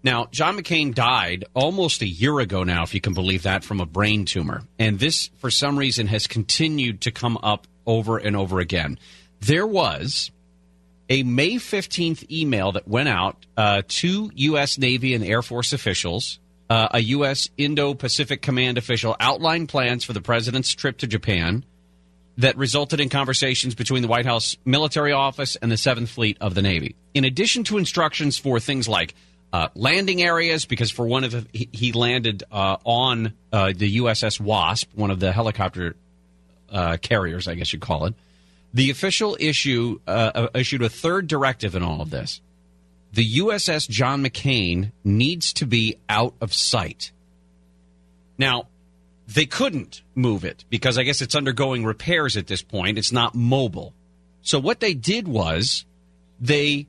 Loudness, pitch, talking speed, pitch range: -21 LUFS, 115 Hz, 170 wpm, 95-135 Hz